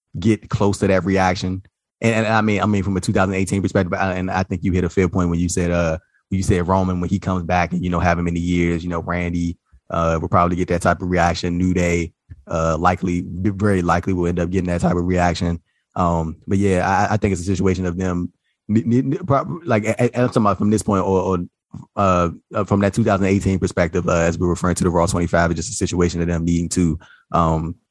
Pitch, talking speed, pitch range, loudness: 90 Hz, 235 wpm, 85-100 Hz, -19 LUFS